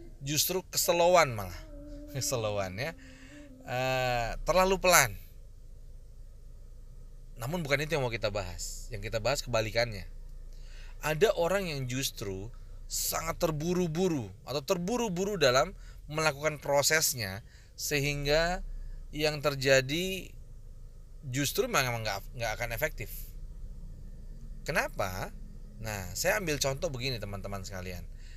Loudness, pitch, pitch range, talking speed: -30 LUFS, 125 Hz, 105-155 Hz, 95 wpm